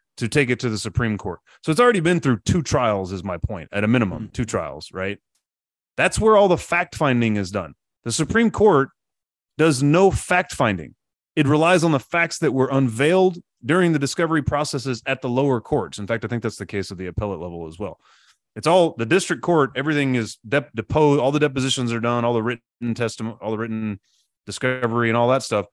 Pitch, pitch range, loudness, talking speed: 125 Hz, 110-155 Hz, -21 LUFS, 215 wpm